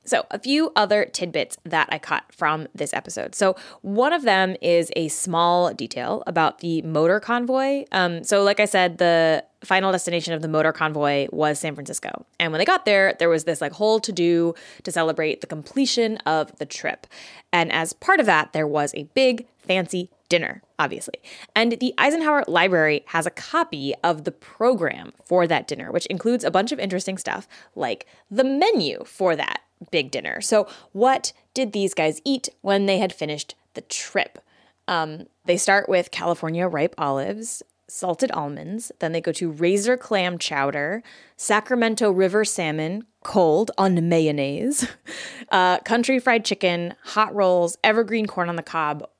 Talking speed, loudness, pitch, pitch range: 170 wpm, -22 LUFS, 185 Hz, 165-220 Hz